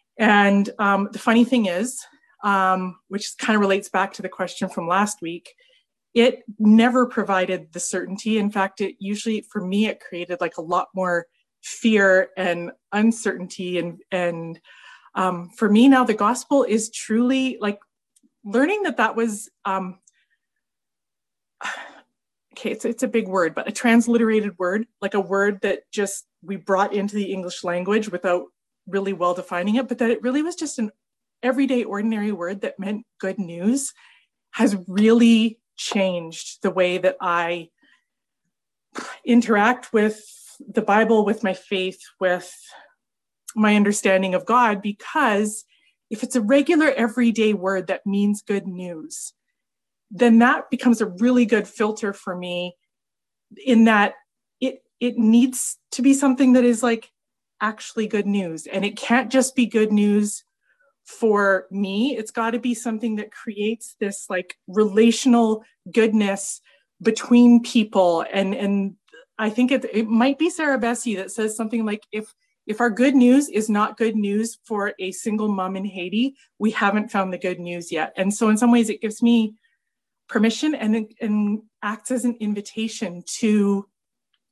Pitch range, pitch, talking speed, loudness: 195-240 Hz, 215 Hz, 155 wpm, -21 LUFS